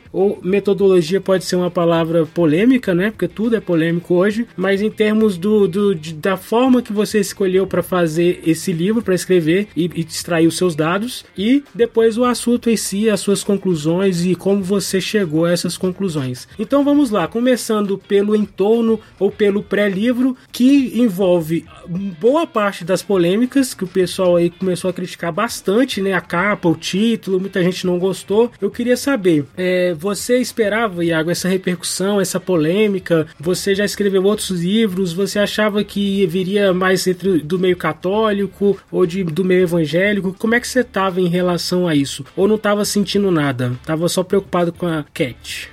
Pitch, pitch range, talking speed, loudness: 190 Hz, 175-210 Hz, 175 wpm, -17 LUFS